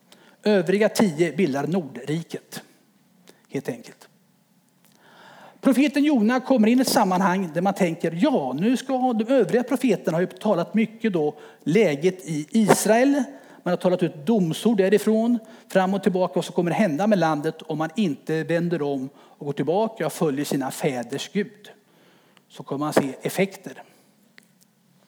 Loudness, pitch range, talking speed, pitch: -23 LUFS, 170-220 Hz, 150 wpm, 200 Hz